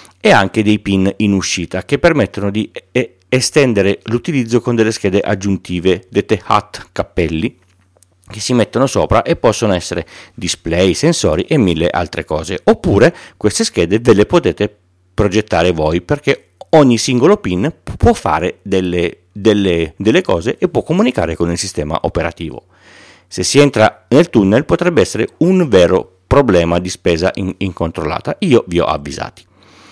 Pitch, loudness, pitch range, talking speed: 100 Hz, -14 LUFS, 90-110 Hz, 150 wpm